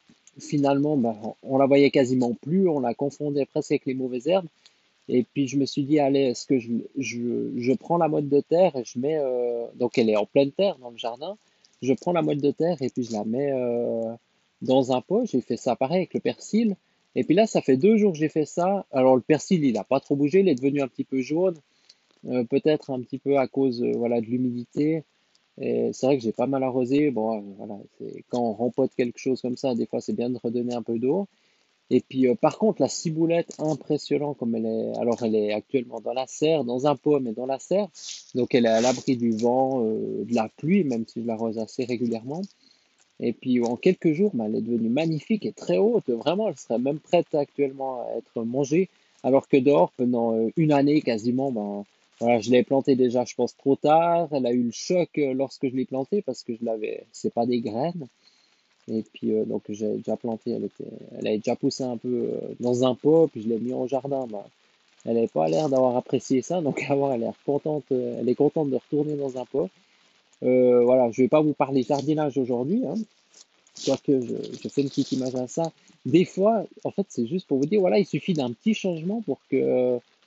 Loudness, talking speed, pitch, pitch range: -25 LUFS, 230 wpm, 135 Hz, 120-155 Hz